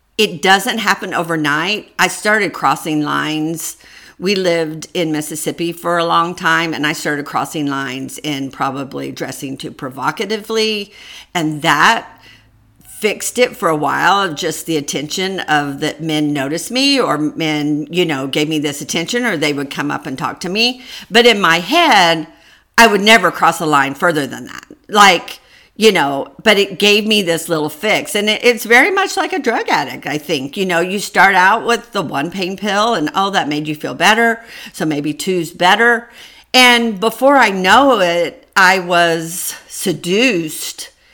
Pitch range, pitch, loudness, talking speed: 155-215 Hz, 170 Hz, -14 LUFS, 180 wpm